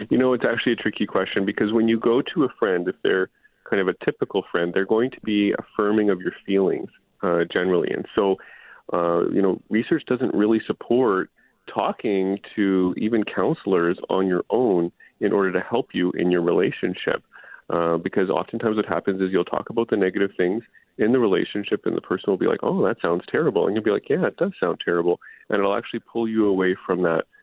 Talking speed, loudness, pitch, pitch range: 210 wpm, -23 LUFS, 100 Hz, 90-110 Hz